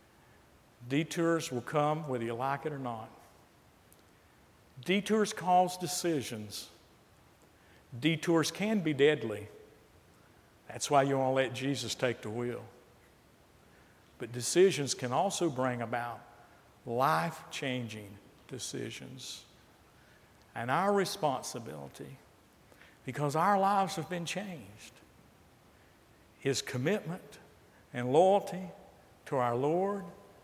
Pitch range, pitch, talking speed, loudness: 120-170 Hz, 135 Hz, 100 wpm, -32 LUFS